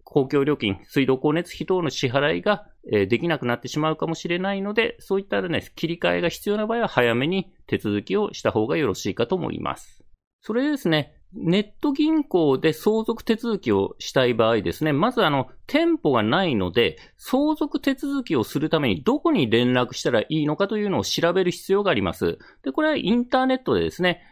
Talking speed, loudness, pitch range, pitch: 395 characters per minute, -23 LUFS, 140-230 Hz, 180 Hz